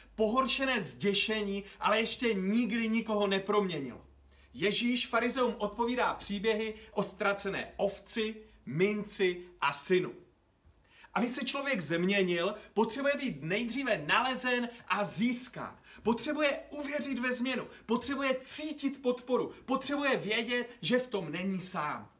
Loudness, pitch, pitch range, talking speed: -32 LUFS, 220 Hz, 200-250 Hz, 110 wpm